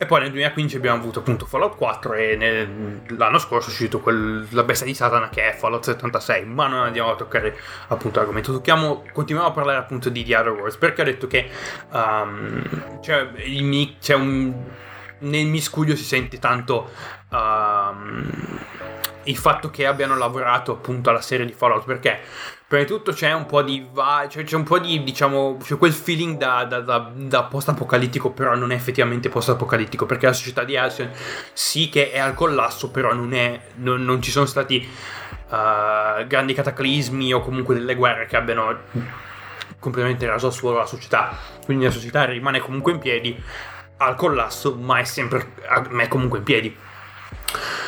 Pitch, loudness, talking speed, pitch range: 125 Hz, -21 LUFS, 180 wpm, 120-140 Hz